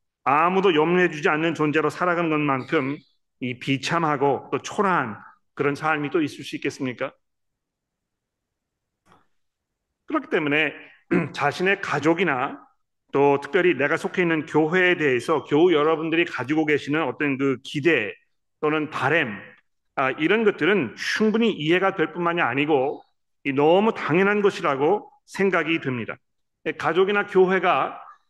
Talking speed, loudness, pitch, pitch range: 285 characters per minute, -22 LUFS, 160 Hz, 145-190 Hz